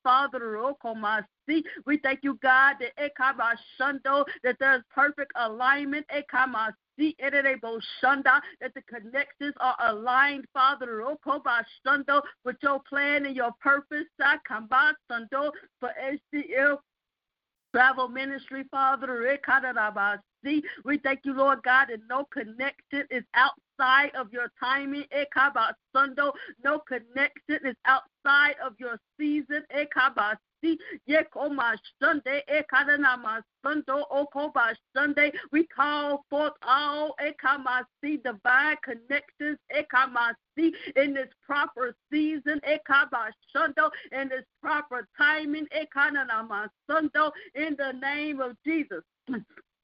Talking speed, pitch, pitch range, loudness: 105 wpm, 275 Hz, 255-295 Hz, -26 LUFS